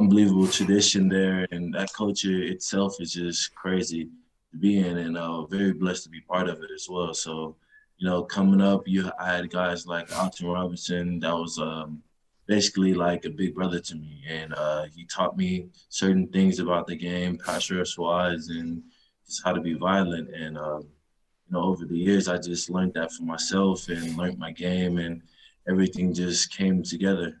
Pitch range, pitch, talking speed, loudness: 85-95 Hz, 90 Hz, 190 wpm, -26 LUFS